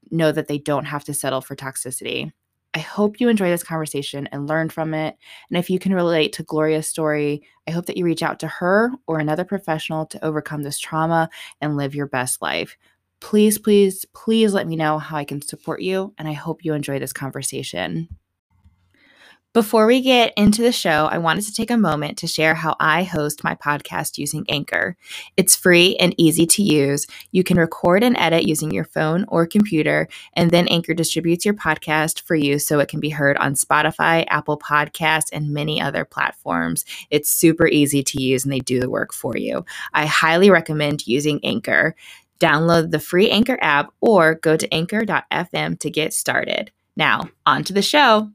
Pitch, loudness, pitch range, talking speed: 160 Hz, -19 LUFS, 150-180 Hz, 195 wpm